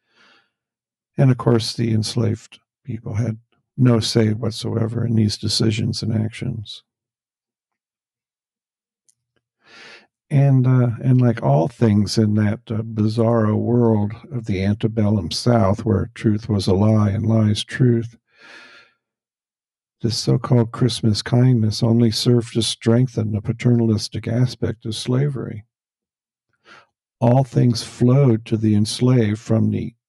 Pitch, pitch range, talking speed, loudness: 115 Hz, 110-120 Hz, 120 wpm, -19 LUFS